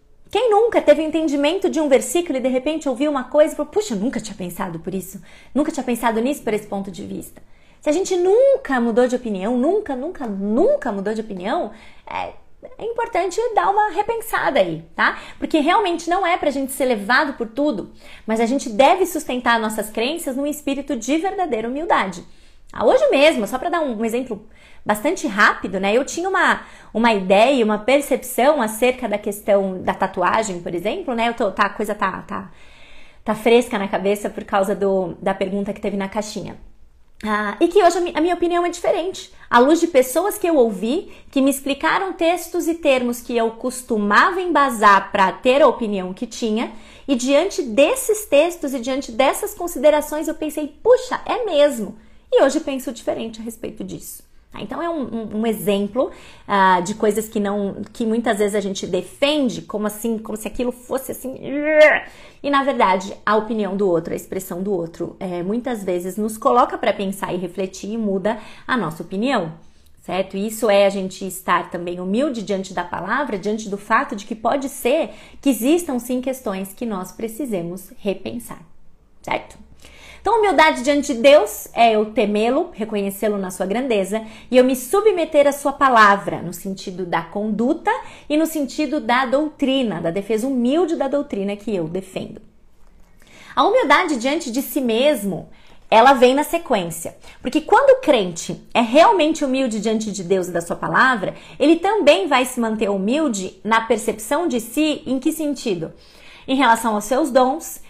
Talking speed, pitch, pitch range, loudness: 185 wpm, 245 Hz, 205-295 Hz, -19 LUFS